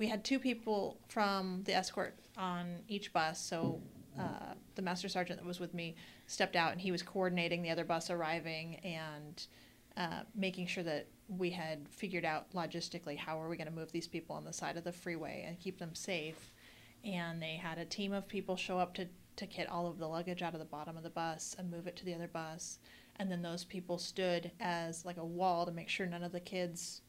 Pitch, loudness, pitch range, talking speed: 175 Hz, -40 LUFS, 165-185 Hz, 230 wpm